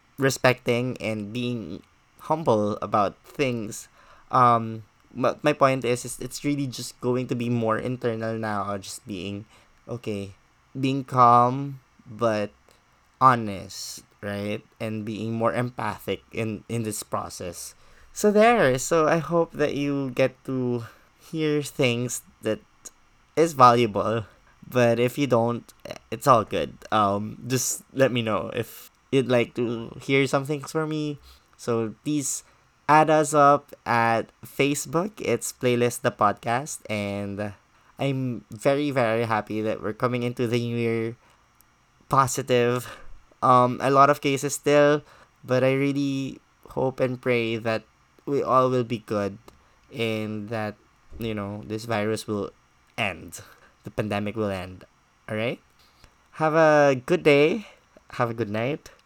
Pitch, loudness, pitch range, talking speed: 120 Hz, -24 LUFS, 110-135 Hz, 135 wpm